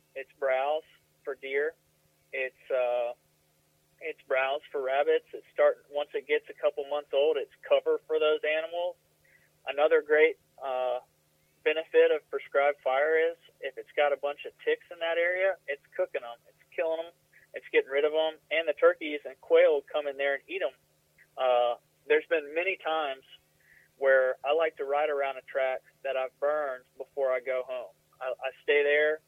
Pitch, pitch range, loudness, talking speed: 150 Hz, 130-185 Hz, -29 LUFS, 180 wpm